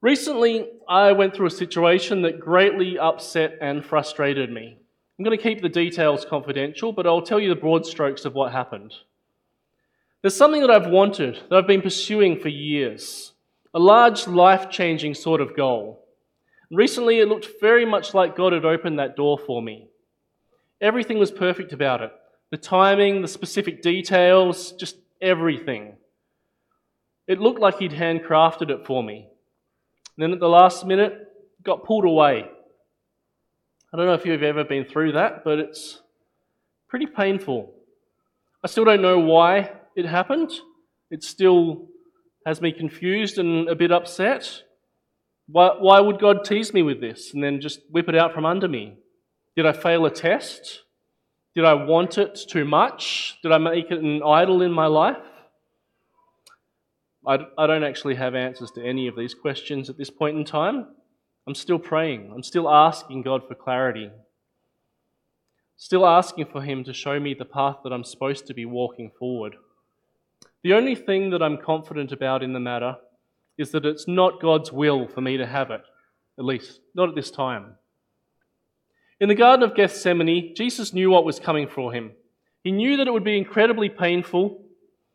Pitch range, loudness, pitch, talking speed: 145-195 Hz, -20 LUFS, 170 Hz, 170 wpm